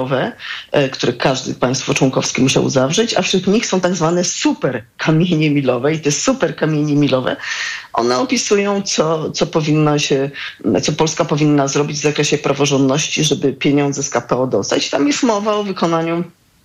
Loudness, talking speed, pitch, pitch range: -16 LUFS, 155 wpm, 150 Hz, 140-175 Hz